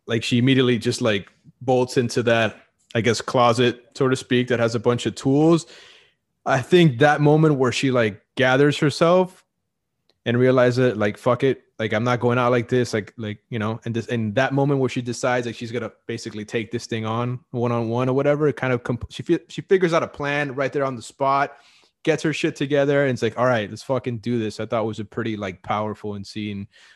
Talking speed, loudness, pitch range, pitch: 235 wpm, -21 LUFS, 115-140 Hz, 125 Hz